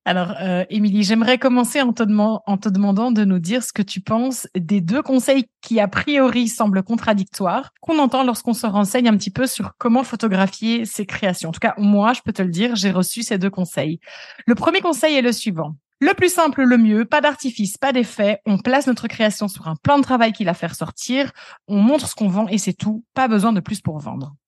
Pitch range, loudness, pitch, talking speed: 200-255 Hz, -19 LUFS, 220 Hz, 225 wpm